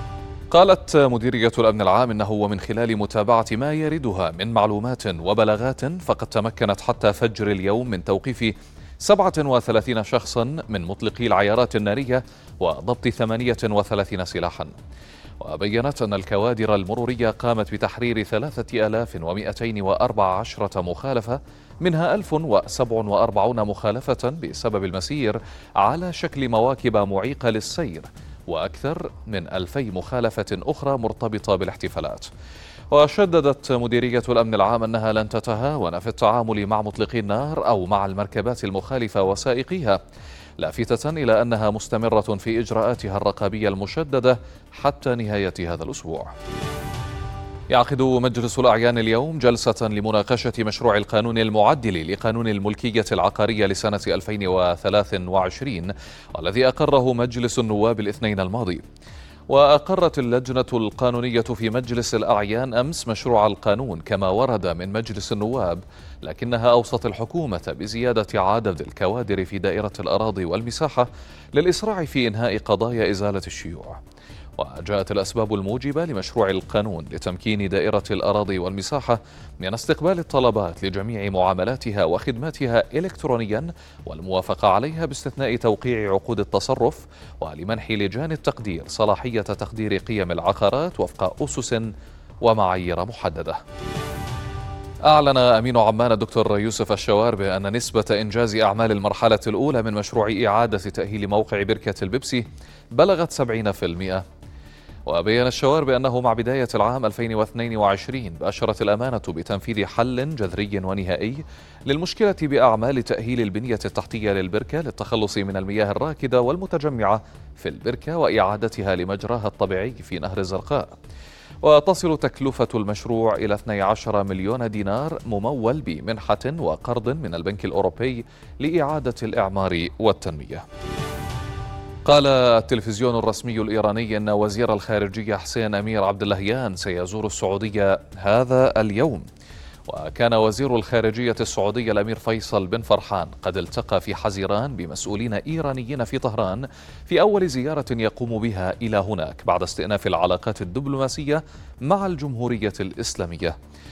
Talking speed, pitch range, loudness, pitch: 110 wpm, 100-125 Hz, -22 LUFS, 110 Hz